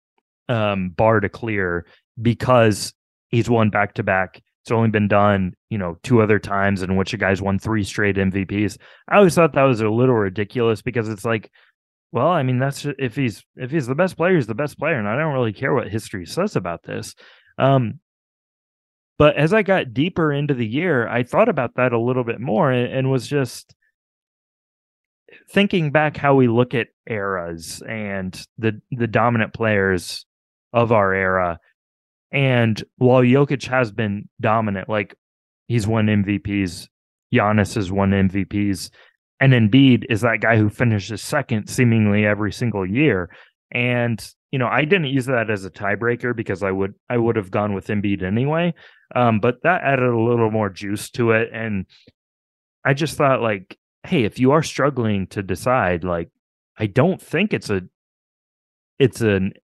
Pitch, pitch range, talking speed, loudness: 115 Hz, 100-130 Hz, 175 wpm, -20 LUFS